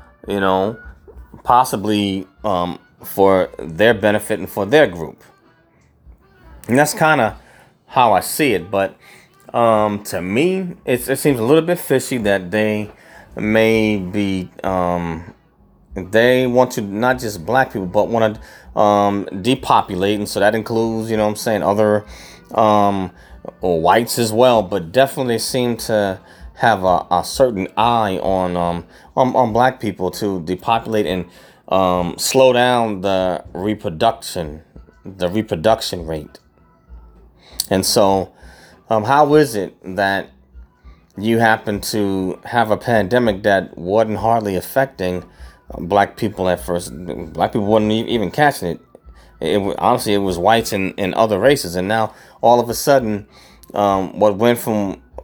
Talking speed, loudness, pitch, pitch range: 145 wpm, -17 LUFS, 105 Hz, 90-115 Hz